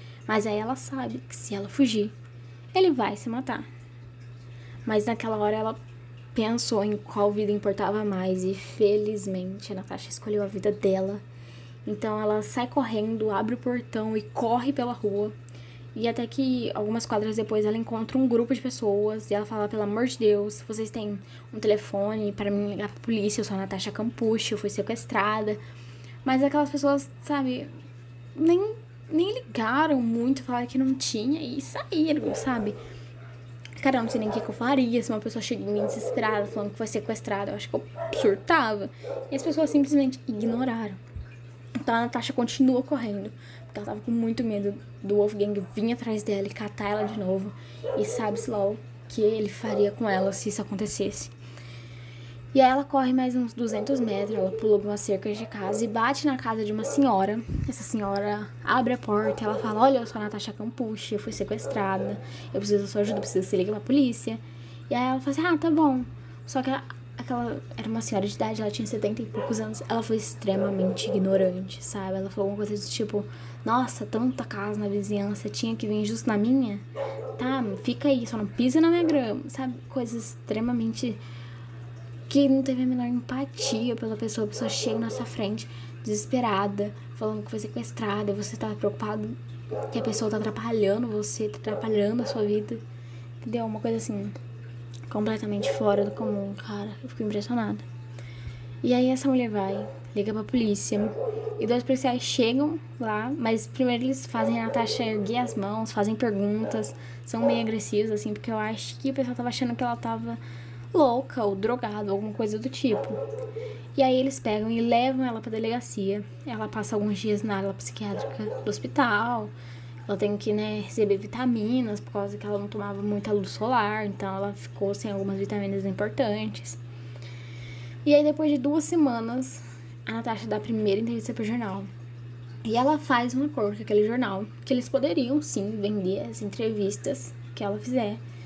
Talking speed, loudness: 185 wpm, -27 LUFS